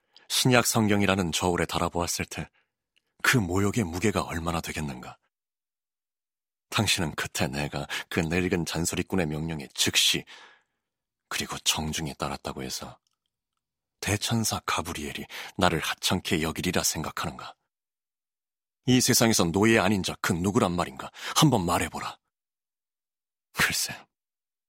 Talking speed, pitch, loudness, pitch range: 265 characters per minute, 90 Hz, -26 LUFS, 80-105 Hz